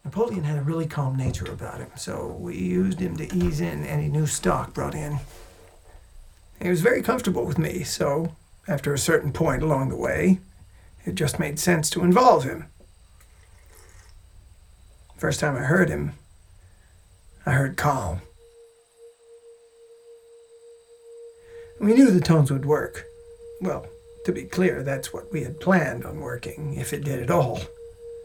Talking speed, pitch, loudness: 150 wpm, 155 Hz, -24 LUFS